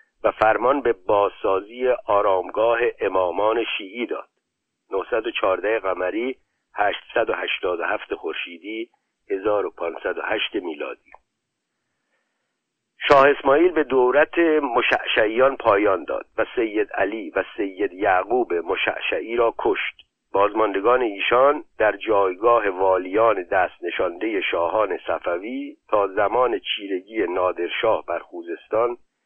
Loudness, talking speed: -21 LUFS, 90 wpm